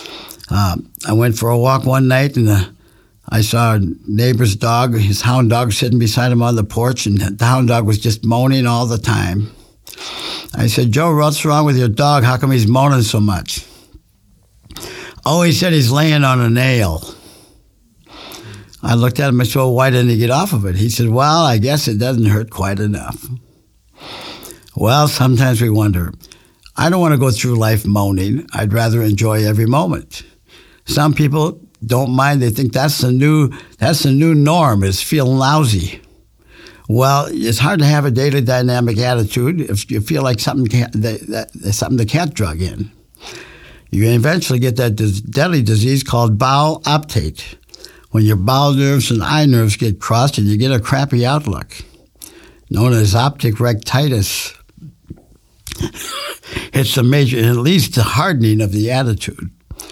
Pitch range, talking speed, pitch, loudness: 110-135 Hz, 175 wpm, 120 Hz, -14 LUFS